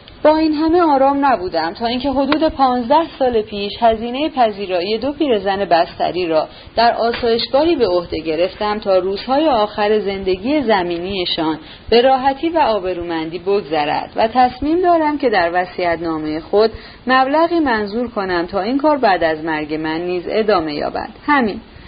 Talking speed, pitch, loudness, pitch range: 150 wpm, 220 Hz, -16 LUFS, 180-275 Hz